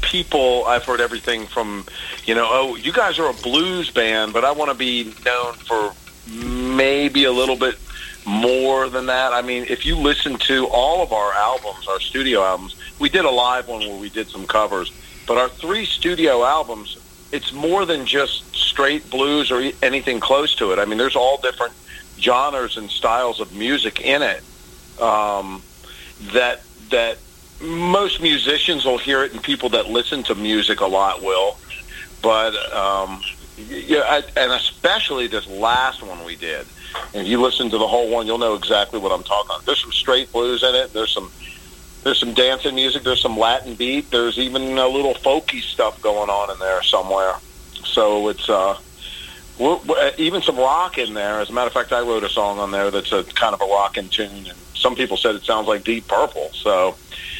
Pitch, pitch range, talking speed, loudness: 120 Hz, 105-130 Hz, 195 wpm, -19 LUFS